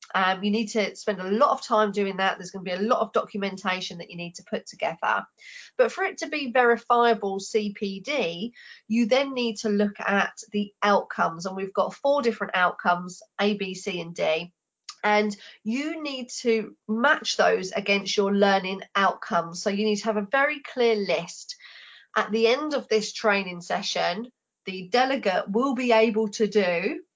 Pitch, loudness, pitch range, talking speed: 210 Hz, -25 LUFS, 195-235 Hz, 185 wpm